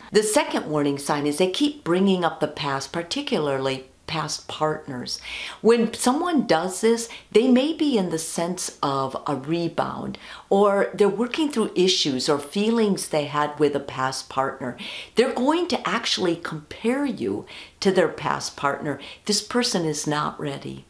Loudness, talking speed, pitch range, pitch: -23 LUFS, 160 wpm, 150-230 Hz, 180 Hz